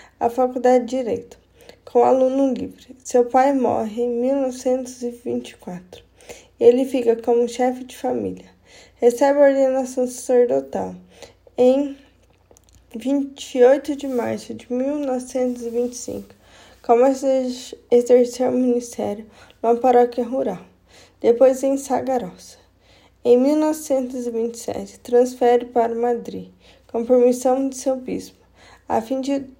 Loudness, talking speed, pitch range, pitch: -20 LUFS, 105 wpm, 235-265 Hz, 250 Hz